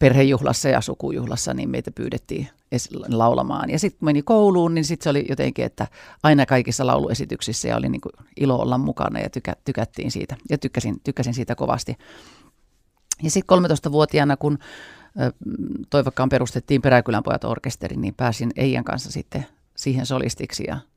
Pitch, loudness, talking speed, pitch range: 135 Hz, -22 LUFS, 140 wpm, 125-150 Hz